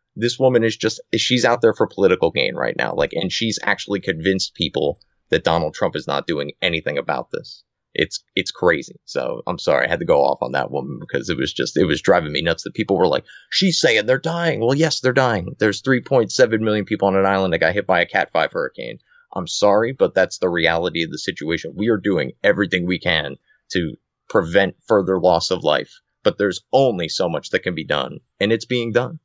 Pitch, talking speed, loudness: 110 Hz, 230 wpm, -19 LUFS